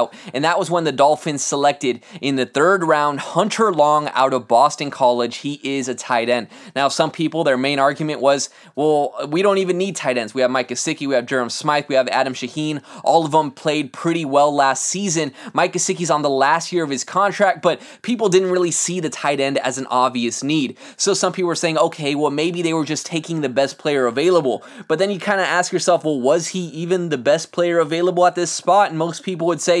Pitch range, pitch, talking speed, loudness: 135-175 Hz, 155 Hz, 235 wpm, -19 LUFS